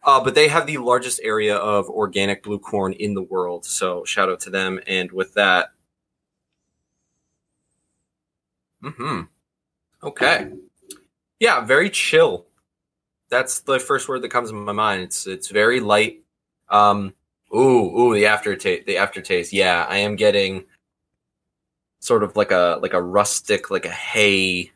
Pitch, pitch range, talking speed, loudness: 105 Hz, 95-125 Hz, 150 wpm, -19 LUFS